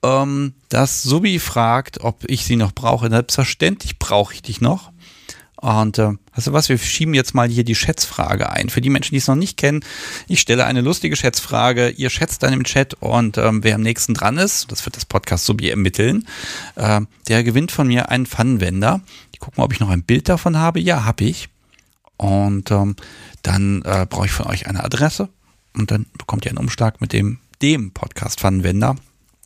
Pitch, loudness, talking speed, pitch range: 120 Hz, -18 LUFS, 200 wpm, 105-135 Hz